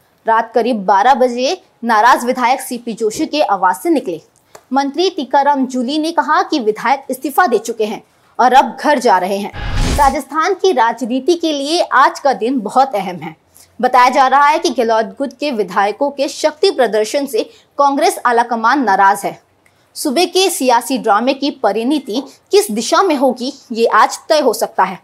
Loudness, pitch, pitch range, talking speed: -14 LUFS, 260 Hz, 225-300 Hz, 175 wpm